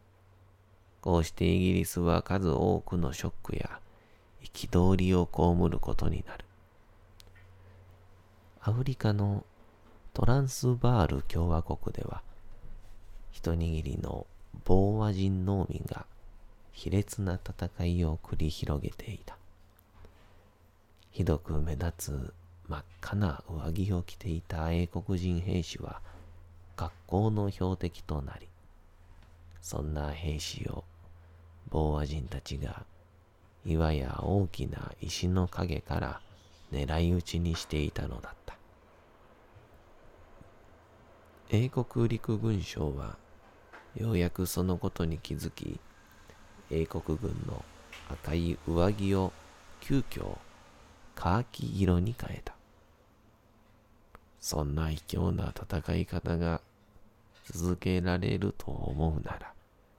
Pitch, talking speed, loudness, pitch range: 90 Hz, 195 characters per minute, -32 LUFS, 85-100 Hz